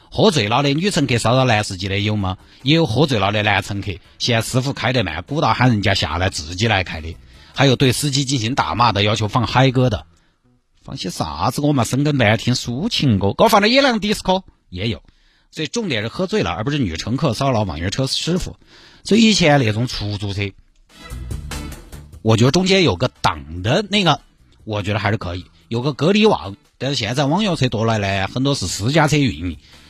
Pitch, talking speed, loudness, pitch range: 120 Hz, 315 characters per minute, -18 LUFS, 100-145 Hz